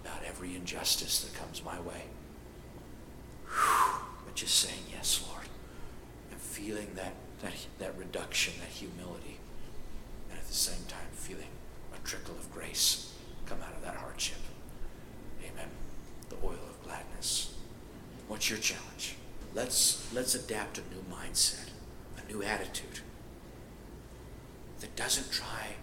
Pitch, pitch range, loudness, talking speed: 95 Hz, 80-105 Hz, -34 LUFS, 130 wpm